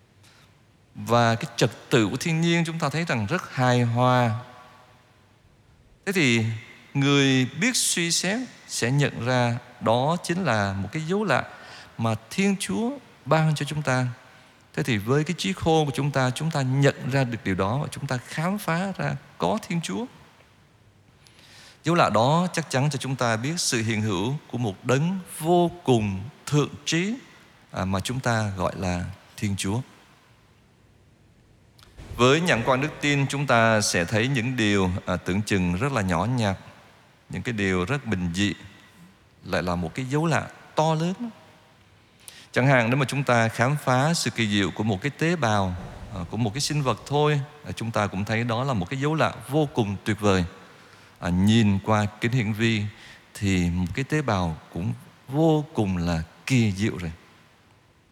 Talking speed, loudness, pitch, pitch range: 180 wpm, -24 LUFS, 125 Hz, 105-145 Hz